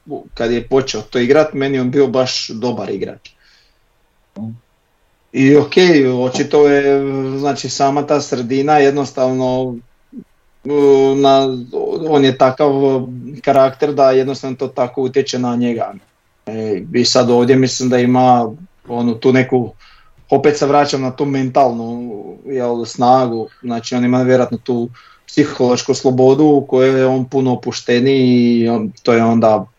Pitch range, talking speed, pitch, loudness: 125-140 Hz, 135 wpm, 130 Hz, -14 LUFS